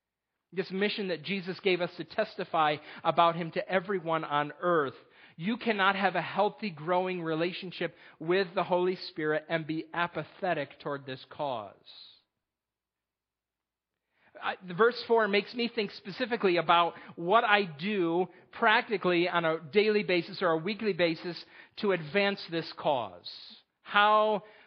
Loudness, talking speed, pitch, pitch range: -29 LUFS, 135 wpm, 180 Hz, 170-205 Hz